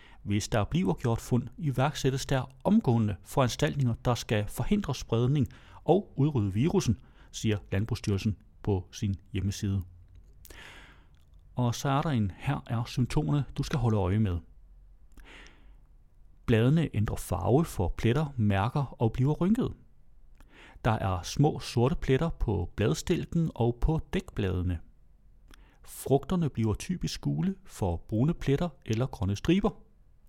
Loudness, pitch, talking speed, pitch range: -29 LUFS, 120 Hz, 125 wpm, 100-145 Hz